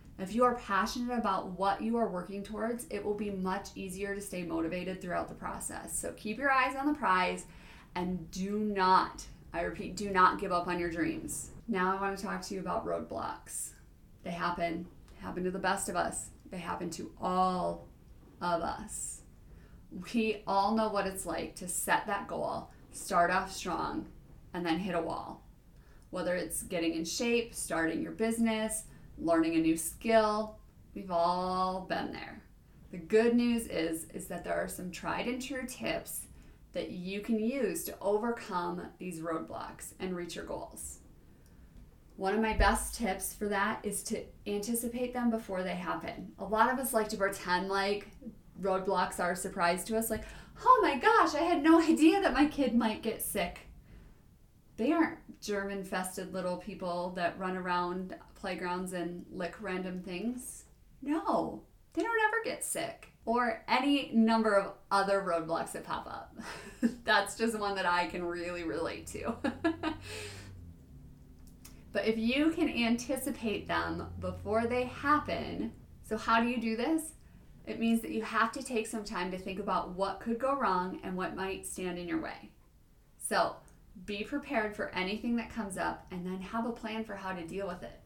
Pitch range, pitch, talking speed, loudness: 180-230 Hz, 195 Hz, 175 wpm, -33 LUFS